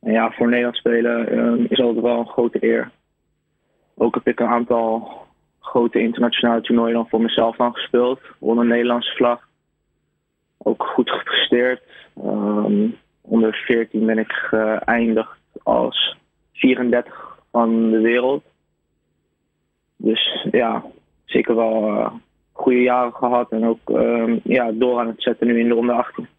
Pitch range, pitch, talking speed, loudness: 110-120 Hz, 115 Hz, 145 wpm, -19 LUFS